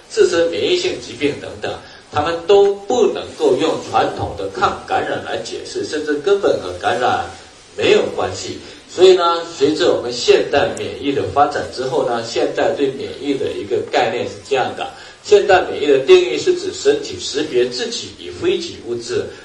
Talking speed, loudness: 270 characters per minute, -17 LUFS